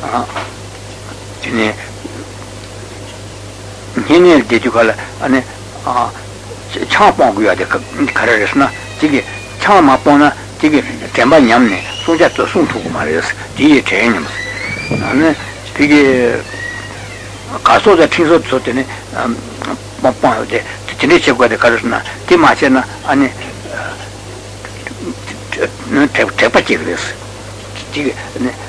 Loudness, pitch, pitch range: -12 LUFS, 105 Hz, 100-125 Hz